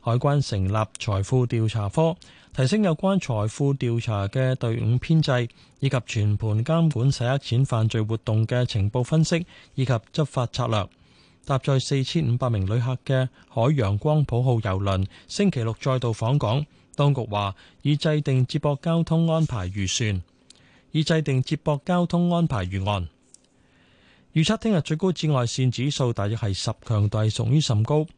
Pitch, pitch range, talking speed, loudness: 125 Hz, 110-150 Hz, 245 characters per minute, -24 LUFS